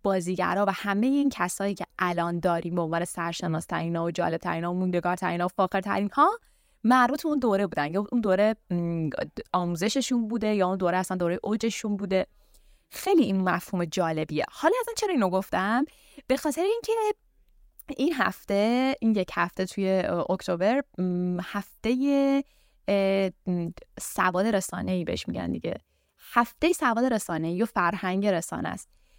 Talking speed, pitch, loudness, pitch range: 150 wpm, 195 Hz, -27 LUFS, 180-245 Hz